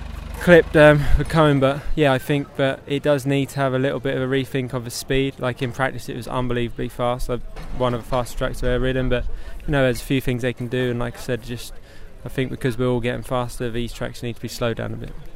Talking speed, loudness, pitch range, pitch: 275 wpm, -21 LUFS, 120-135 Hz, 125 Hz